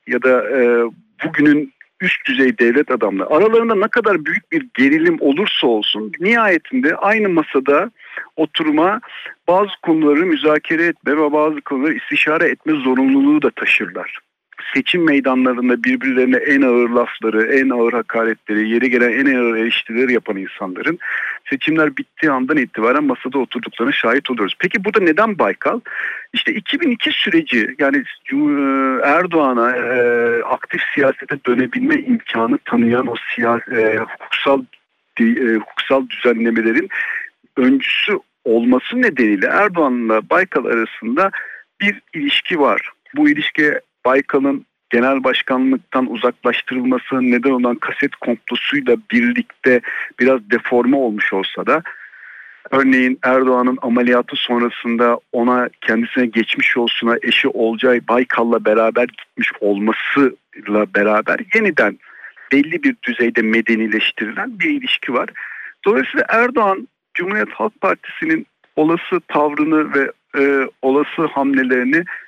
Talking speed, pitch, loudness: 115 wpm, 135 Hz, -16 LUFS